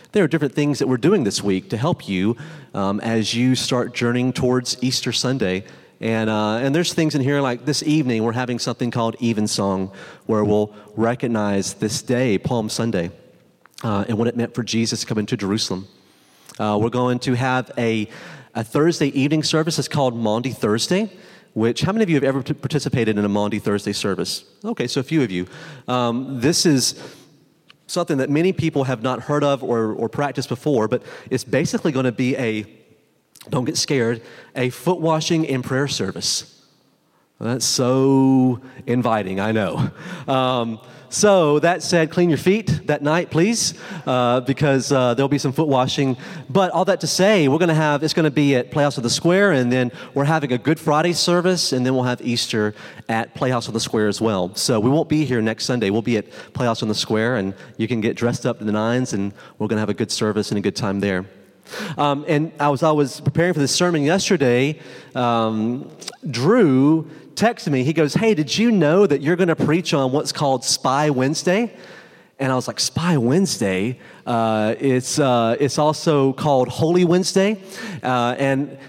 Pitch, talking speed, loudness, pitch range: 130 Hz, 200 wpm, -20 LUFS, 115-155 Hz